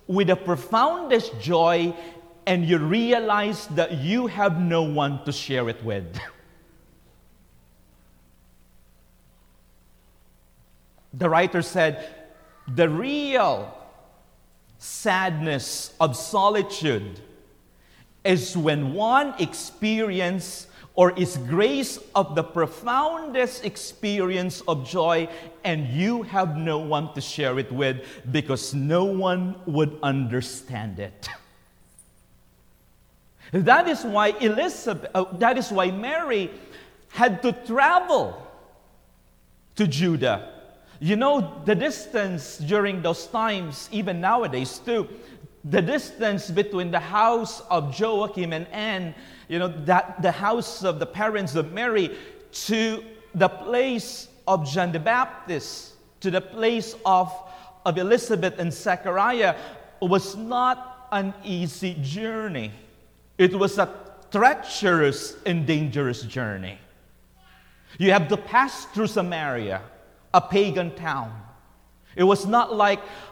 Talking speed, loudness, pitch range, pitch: 110 wpm, -24 LUFS, 145-210 Hz, 180 Hz